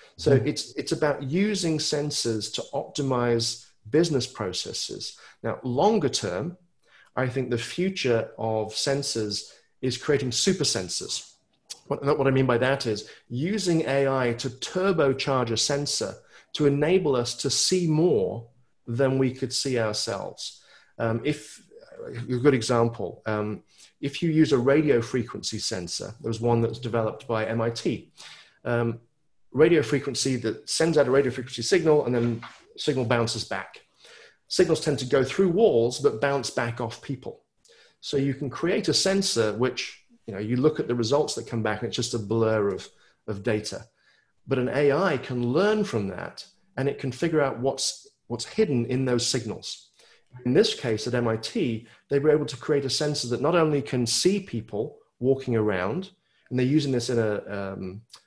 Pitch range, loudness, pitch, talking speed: 115-145 Hz, -25 LUFS, 130 Hz, 170 wpm